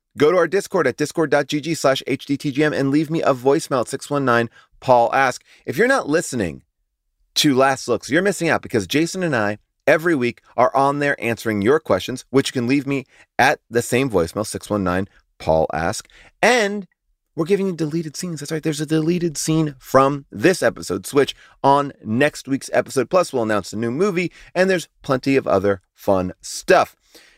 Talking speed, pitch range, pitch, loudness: 180 wpm, 115-160 Hz, 135 Hz, -20 LUFS